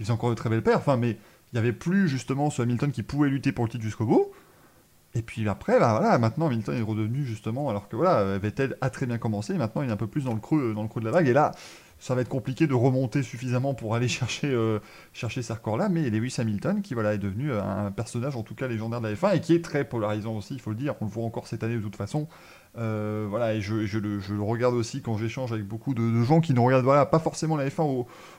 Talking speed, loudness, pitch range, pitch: 285 wpm, -27 LUFS, 110-140 Hz, 120 Hz